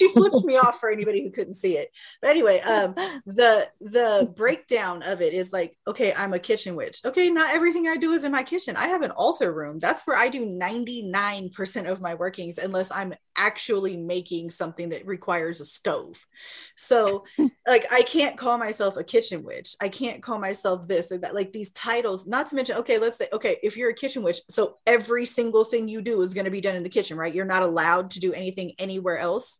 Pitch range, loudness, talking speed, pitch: 185-255 Hz, -24 LUFS, 220 wpm, 215 Hz